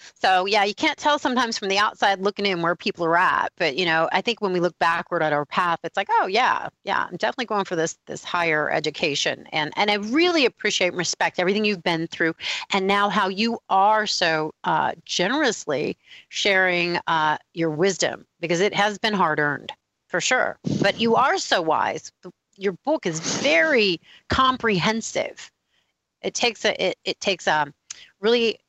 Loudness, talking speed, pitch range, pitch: -22 LUFS, 185 wpm, 170-215 Hz, 195 Hz